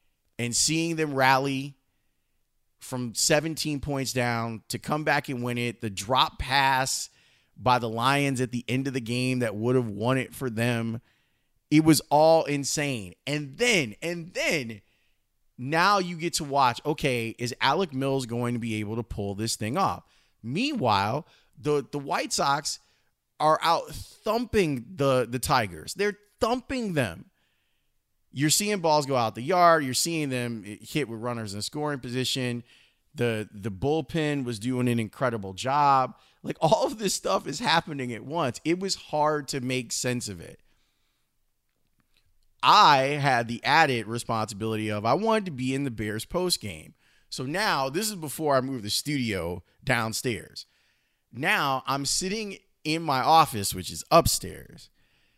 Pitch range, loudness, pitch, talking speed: 115-150 Hz, -26 LUFS, 130 Hz, 160 wpm